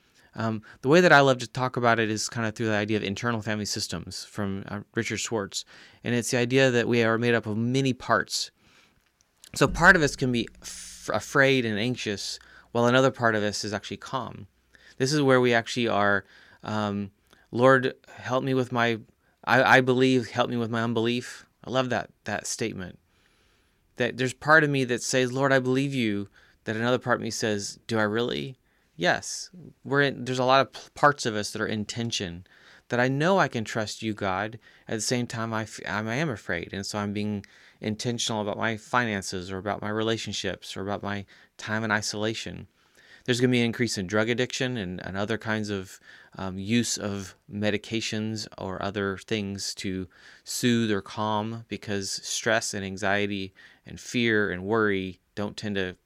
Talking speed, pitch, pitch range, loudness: 195 wpm, 110 Hz, 100-125 Hz, -26 LUFS